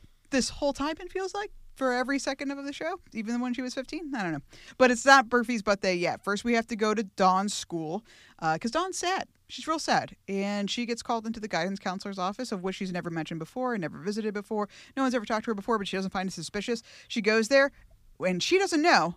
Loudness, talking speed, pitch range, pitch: -28 LUFS, 250 wpm, 195-270 Hz, 230 Hz